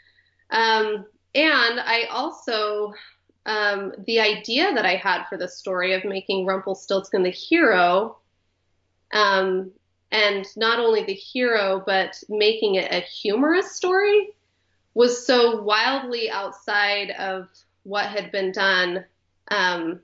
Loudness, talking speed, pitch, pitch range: -21 LUFS, 120 wpm, 205 Hz, 190-230 Hz